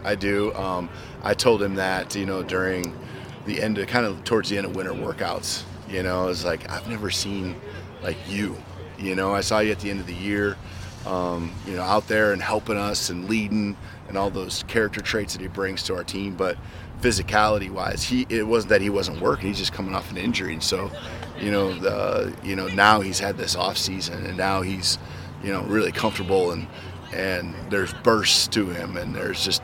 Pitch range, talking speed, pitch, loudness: 95-105 Hz, 220 wpm, 95 Hz, -24 LUFS